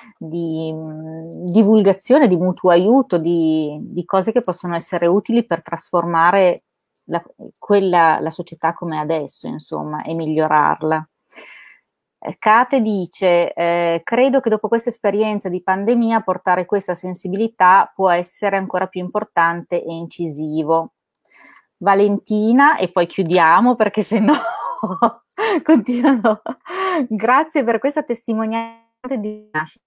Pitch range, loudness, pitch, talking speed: 170-230 Hz, -17 LUFS, 190 Hz, 115 wpm